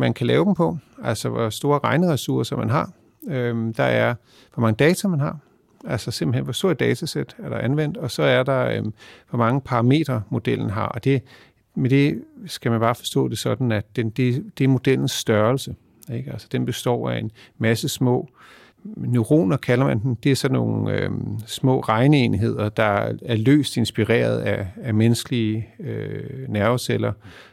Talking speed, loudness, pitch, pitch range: 180 wpm, -22 LUFS, 125 Hz, 115-135 Hz